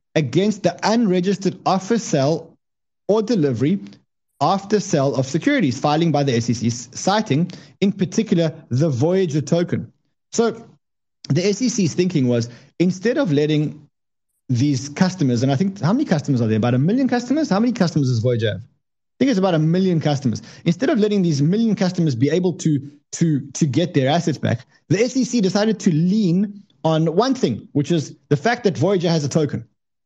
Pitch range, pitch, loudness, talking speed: 140-195 Hz, 165 Hz, -19 LUFS, 175 wpm